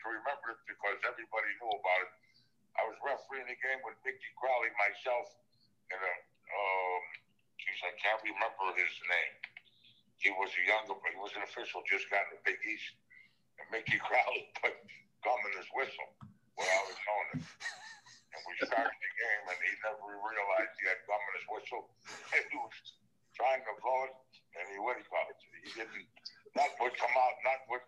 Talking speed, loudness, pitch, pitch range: 185 wpm, -36 LUFS, 110 Hz, 100-120 Hz